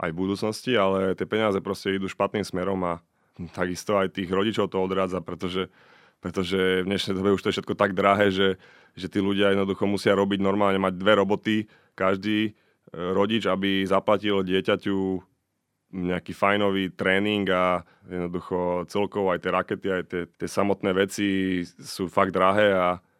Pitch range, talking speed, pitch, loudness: 95-100 Hz, 160 wpm, 95 Hz, -25 LUFS